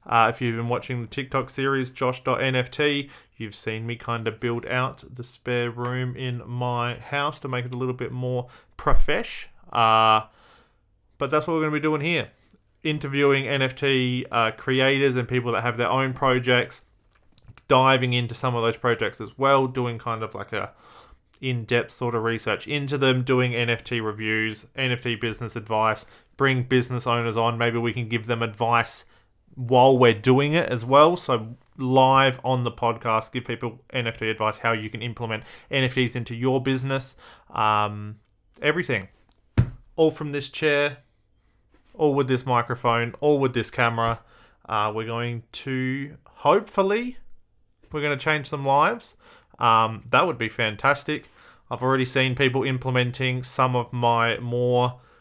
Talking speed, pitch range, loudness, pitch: 160 wpm, 115-135 Hz, -23 LUFS, 125 Hz